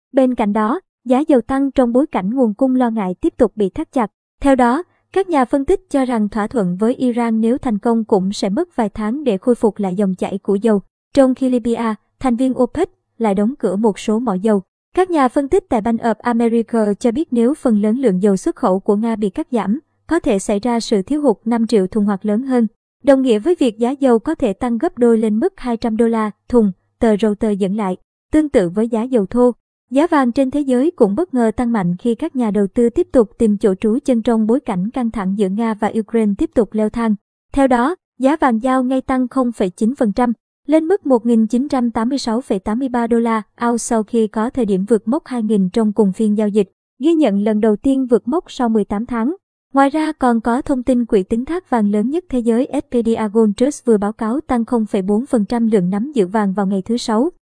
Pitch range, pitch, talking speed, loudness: 215-260 Hz, 235 Hz, 230 wpm, -17 LUFS